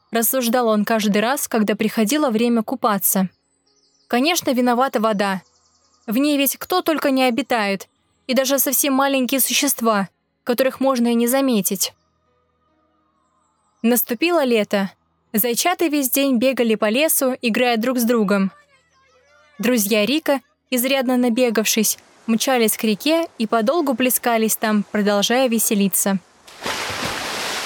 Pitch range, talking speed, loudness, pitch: 215-270 Hz, 115 wpm, -19 LUFS, 245 Hz